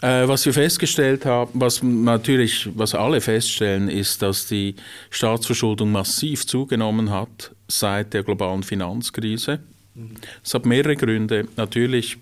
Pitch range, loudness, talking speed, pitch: 105-125 Hz, -20 LUFS, 125 wpm, 115 Hz